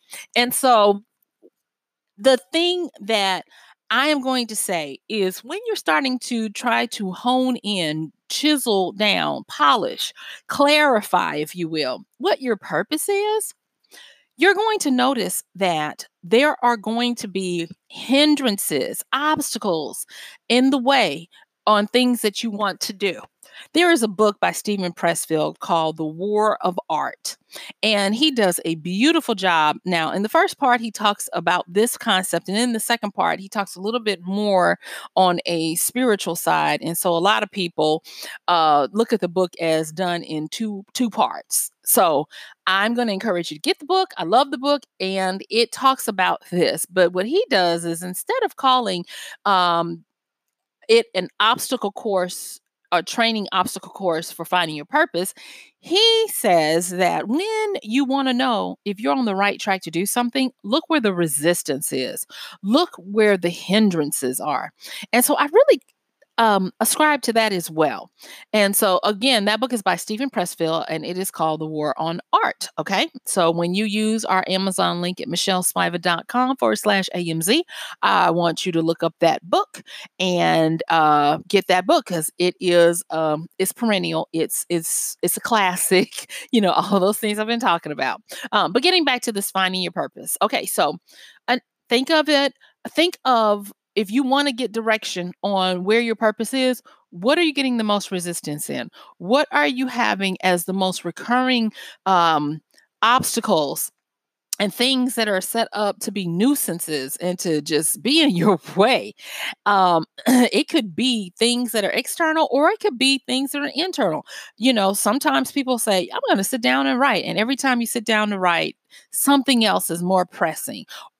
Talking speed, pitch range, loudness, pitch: 175 wpm, 180-255 Hz, -20 LUFS, 210 Hz